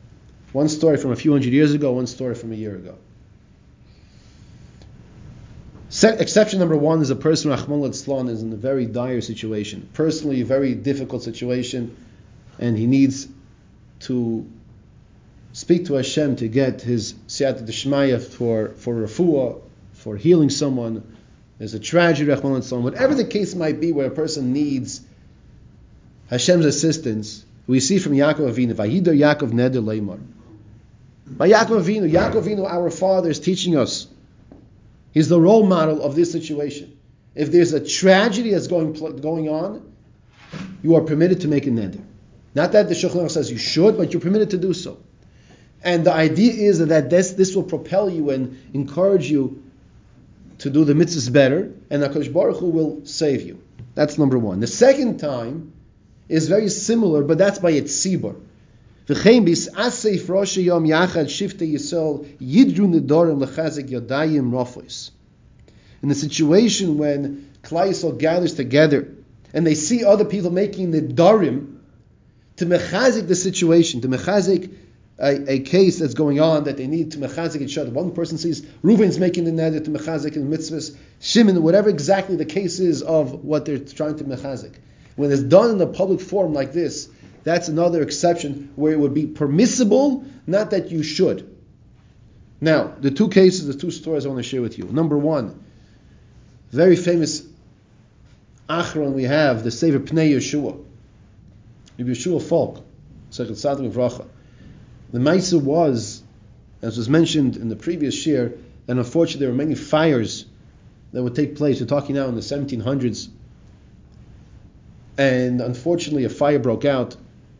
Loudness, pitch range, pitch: -19 LUFS, 125-170 Hz, 145 Hz